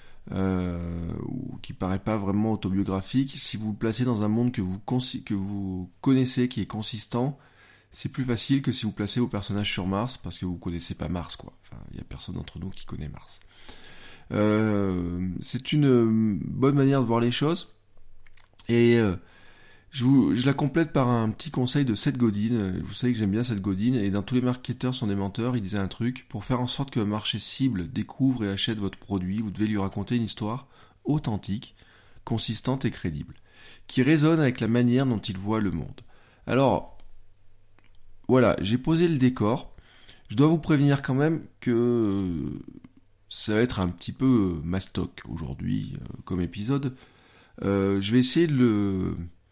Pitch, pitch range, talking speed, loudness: 110 Hz, 100-125 Hz, 185 wpm, -26 LUFS